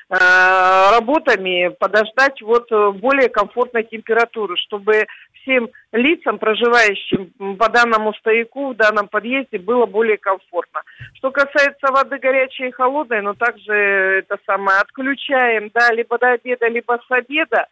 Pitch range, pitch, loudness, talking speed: 210-255 Hz, 230 Hz, -16 LUFS, 125 wpm